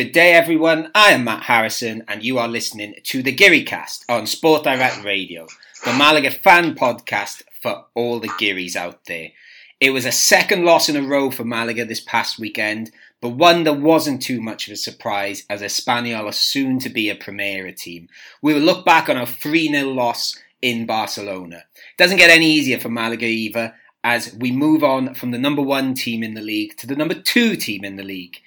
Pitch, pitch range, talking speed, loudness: 120 Hz, 110-145 Hz, 205 wpm, -17 LUFS